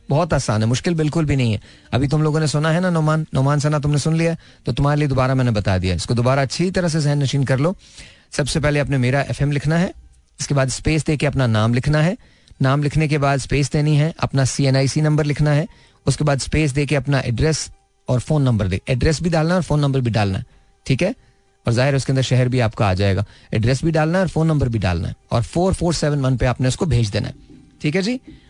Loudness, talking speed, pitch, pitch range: -19 LUFS, 145 wpm, 140 Hz, 125-155 Hz